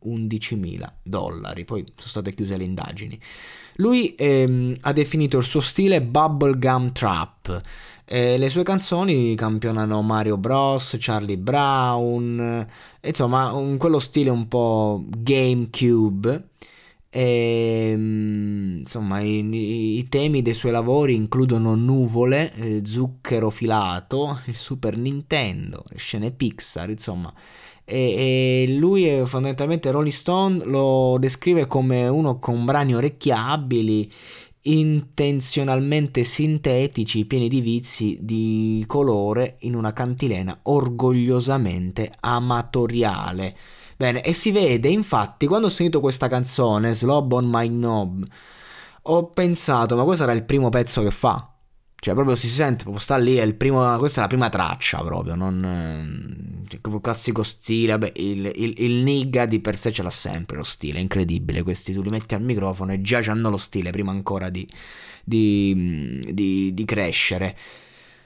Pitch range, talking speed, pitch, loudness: 110-135 Hz, 140 wpm, 120 Hz, -21 LUFS